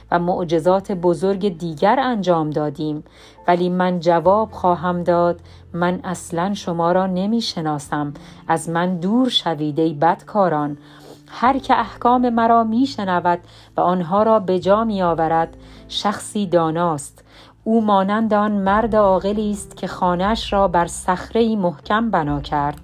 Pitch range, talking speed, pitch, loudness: 165-205 Hz, 135 wpm, 180 Hz, -19 LUFS